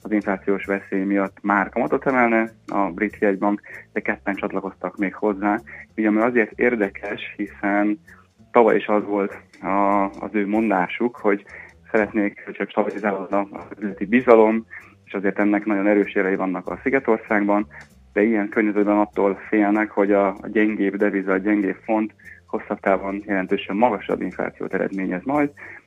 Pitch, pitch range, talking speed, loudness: 105 Hz, 100-110 Hz, 145 wpm, -21 LUFS